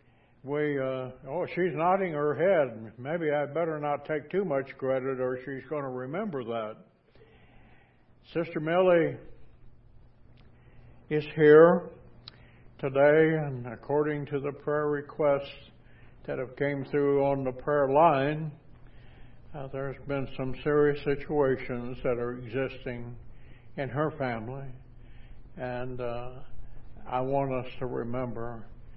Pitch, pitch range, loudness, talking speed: 135 Hz, 125-150 Hz, -28 LUFS, 120 wpm